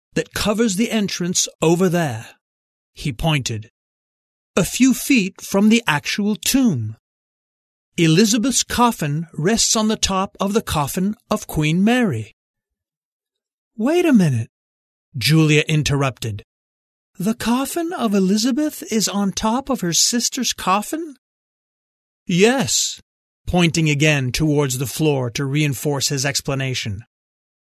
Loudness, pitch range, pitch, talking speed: -18 LUFS, 140-225 Hz, 175 Hz, 115 wpm